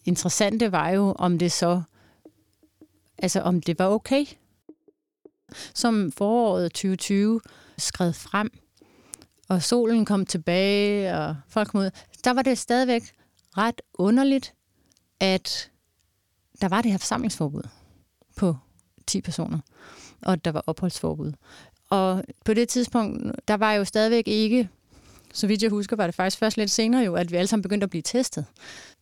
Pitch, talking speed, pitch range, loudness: 200 Hz, 150 wpm, 175-230 Hz, -24 LUFS